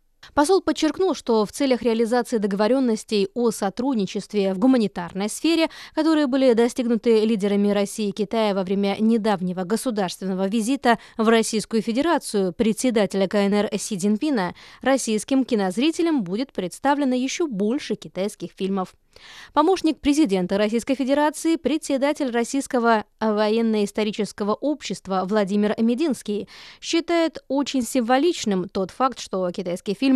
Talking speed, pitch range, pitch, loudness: 115 wpm, 205-270 Hz, 225 Hz, -22 LUFS